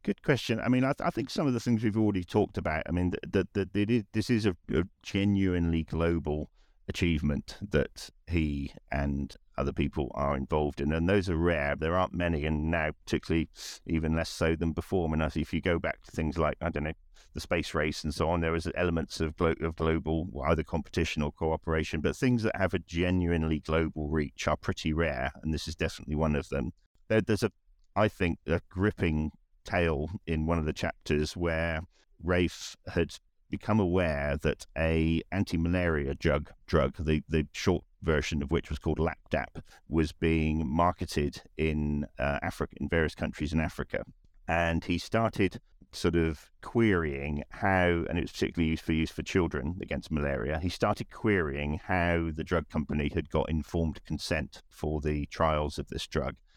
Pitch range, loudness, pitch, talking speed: 75-90 Hz, -30 LUFS, 80 Hz, 190 wpm